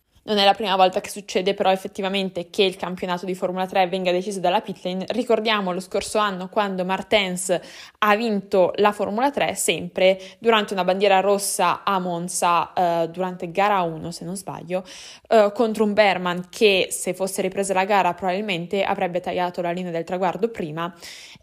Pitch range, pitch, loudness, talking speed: 180-205 Hz, 190 Hz, -22 LUFS, 175 wpm